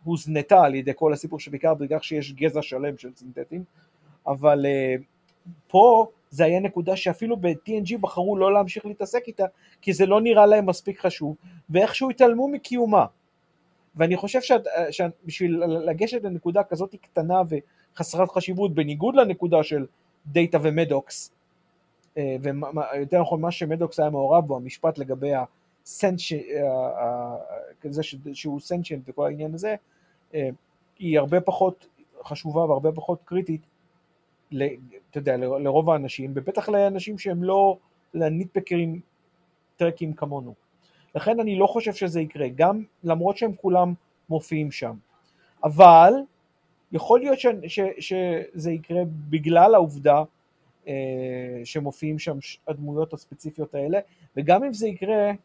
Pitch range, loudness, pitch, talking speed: 150-190 Hz, -23 LUFS, 170 Hz, 120 wpm